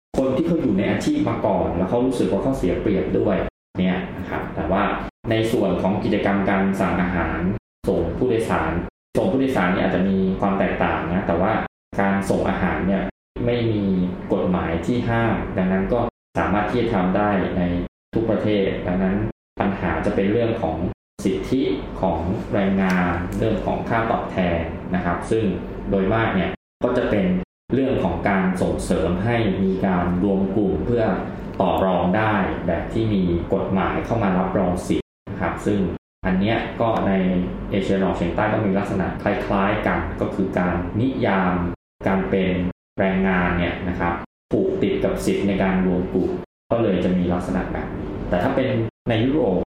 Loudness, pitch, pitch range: -22 LUFS, 95 Hz, 90-105 Hz